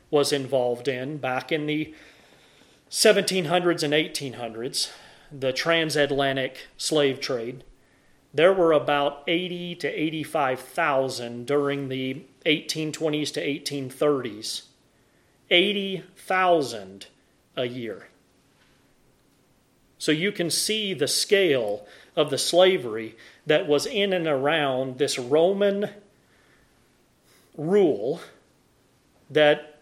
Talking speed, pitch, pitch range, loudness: 90 wpm, 150 Hz, 130-170 Hz, -24 LUFS